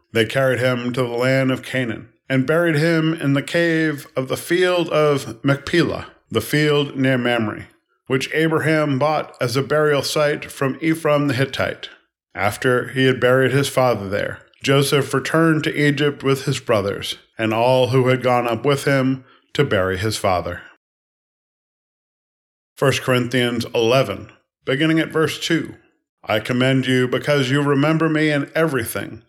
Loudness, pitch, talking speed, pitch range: -19 LUFS, 135 Hz, 155 wpm, 125-150 Hz